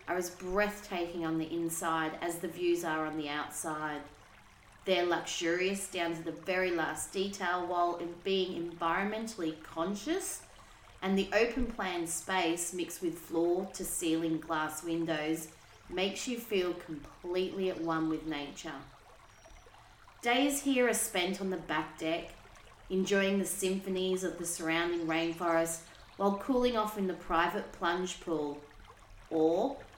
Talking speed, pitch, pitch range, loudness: 130 wpm, 170 Hz, 160-190 Hz, -33 LUFS